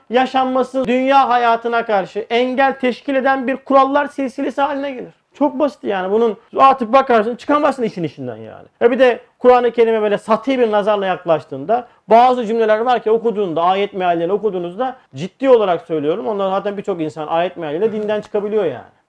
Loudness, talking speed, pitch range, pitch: -16 LUFS, 165 wpm, 205-260 Hz, 230 Hz